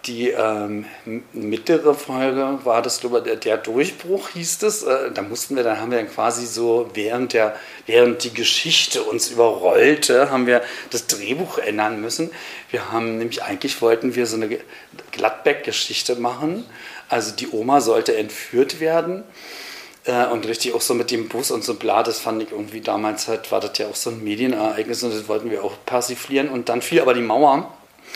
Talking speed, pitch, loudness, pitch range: 185 wpm, 120 Hz, -20 LUFS, 115-165 Hz